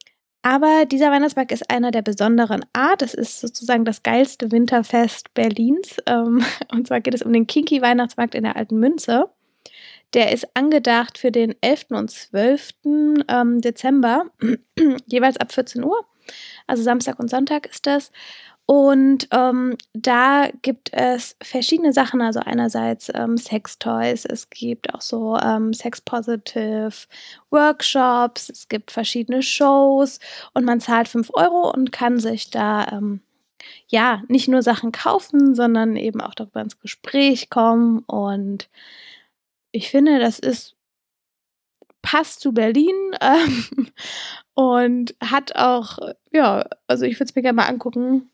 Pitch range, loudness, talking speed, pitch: 230-275 Hz, -19 LUFS, 140 wpm, 245 Hz